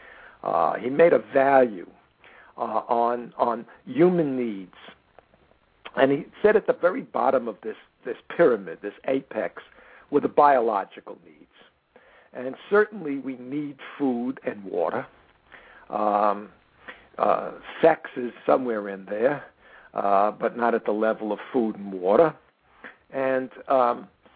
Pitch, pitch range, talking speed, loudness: 130 Hz, 110-145 Hz, 130 wpm, -24 LUFS